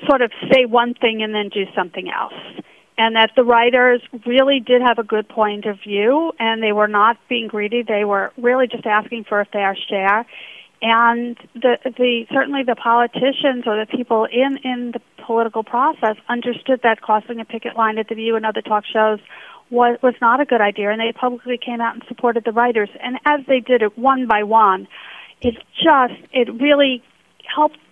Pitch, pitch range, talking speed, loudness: 235 Hz, 220-250 Hz, 200 wpm, -17 LUFS